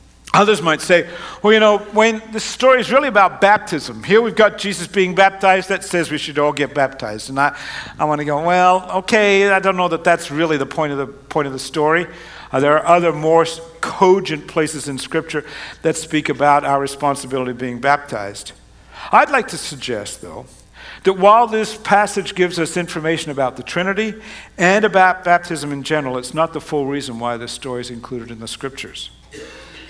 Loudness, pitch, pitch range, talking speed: -16 LUFS, 160 Hz, 140-195 Hz, 195 wpm